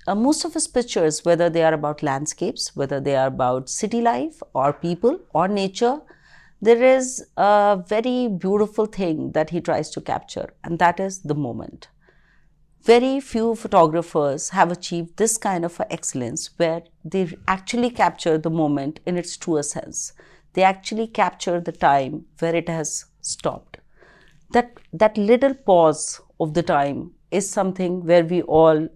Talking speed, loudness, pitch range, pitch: 160 wpm, -21 LUFS, 160-215 Hz, 175 Hz